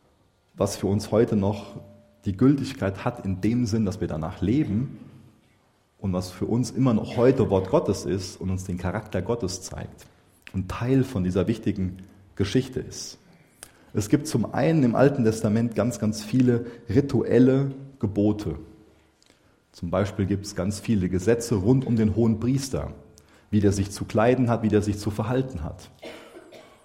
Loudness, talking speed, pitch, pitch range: -25 LUFS, 165 wpm, 110 Hz, 100-120 Hz